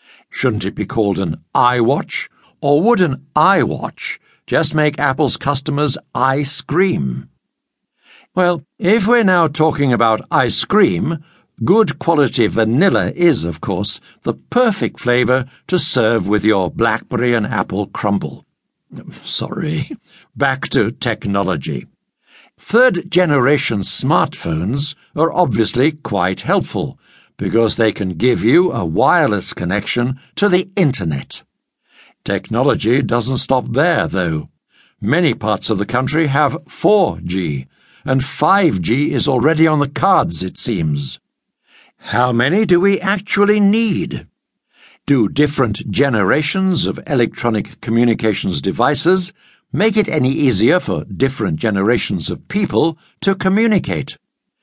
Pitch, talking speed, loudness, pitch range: 145 Hz, 120 wpm, -16 LUFS, 115-175 Hz